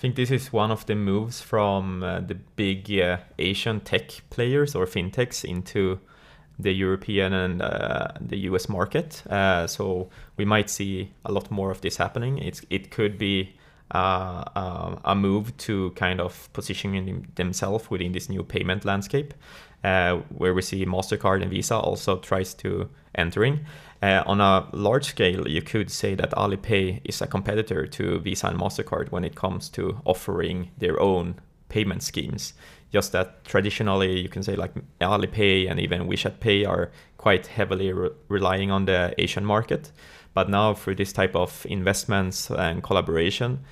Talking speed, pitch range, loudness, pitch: 170 wpm, 95-105 Hz, -25 LUFS, 95 Hz